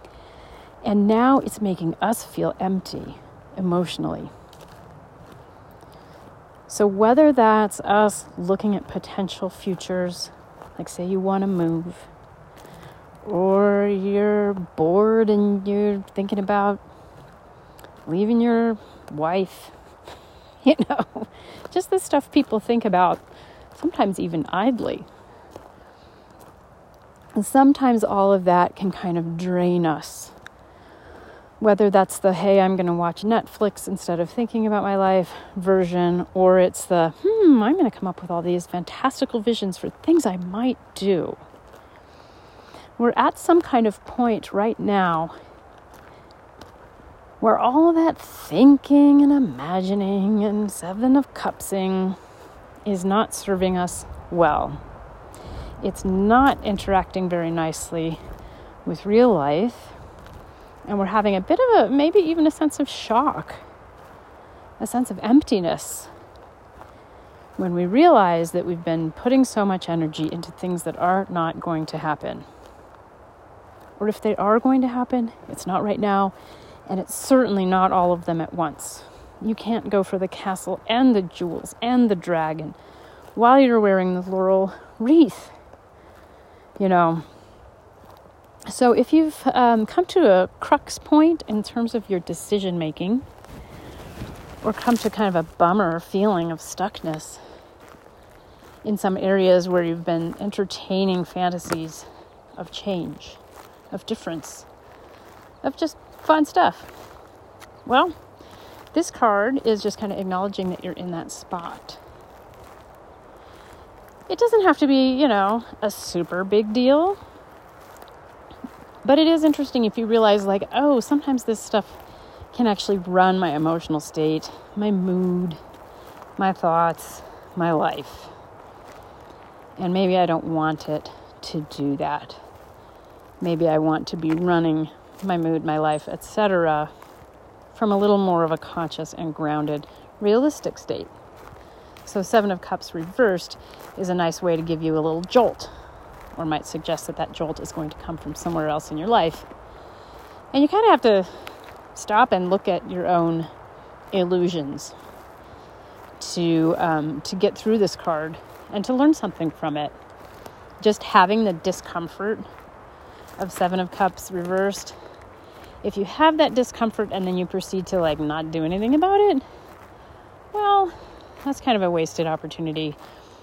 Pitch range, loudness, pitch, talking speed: 170-225 Hz, -21 LUFS, 195 Hz, 140 wpm